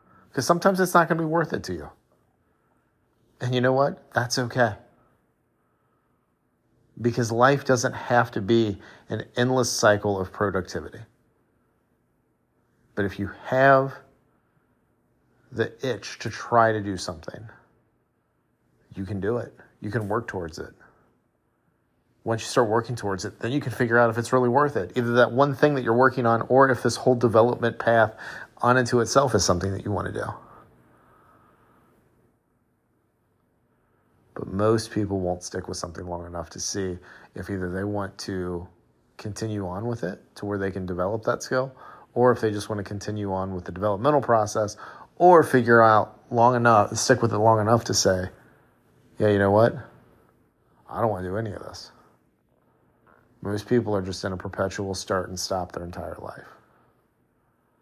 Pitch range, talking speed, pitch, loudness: 95-125 Hz, 170 wpm, 110 Hz, -23 LUFS